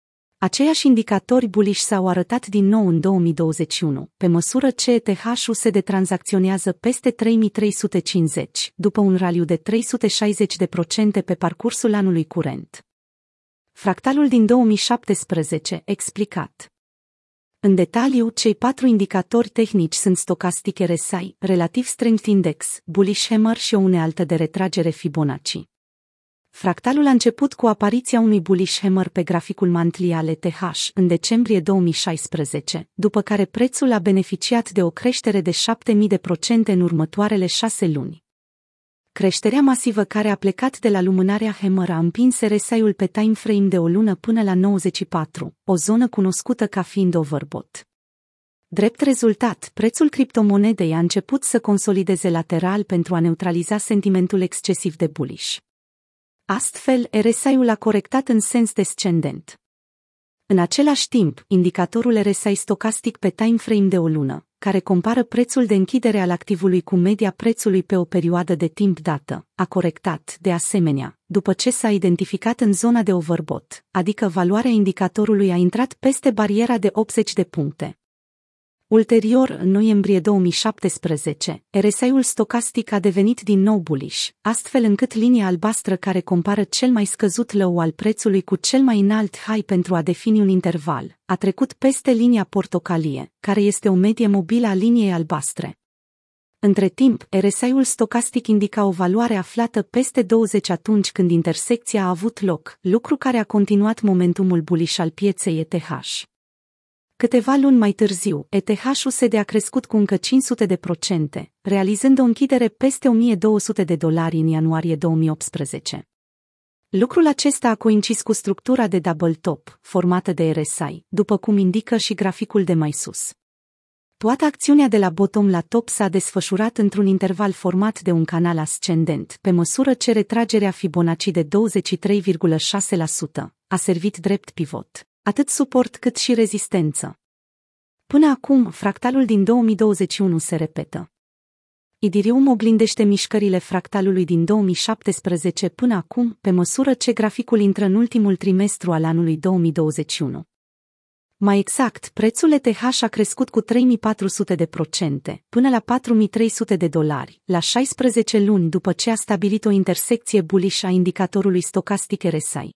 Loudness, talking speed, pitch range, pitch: -19 LUFS, 140 wpm, 180-225 Hz, 200 Hz